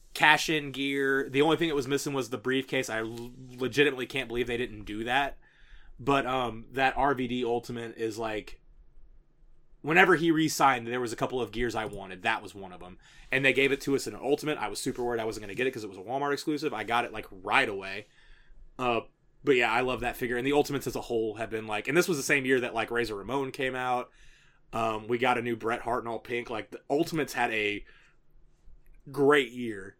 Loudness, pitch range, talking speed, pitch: -29 LUFS, 115-140 Hz, 240 wpm, 125 Hz